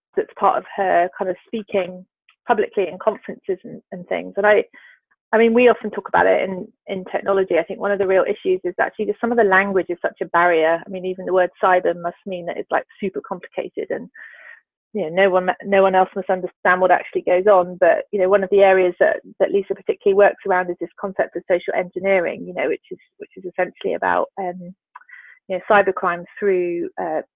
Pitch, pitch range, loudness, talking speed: 195 Hz, 180-230 Hz, -19 LUFS, 225 wpm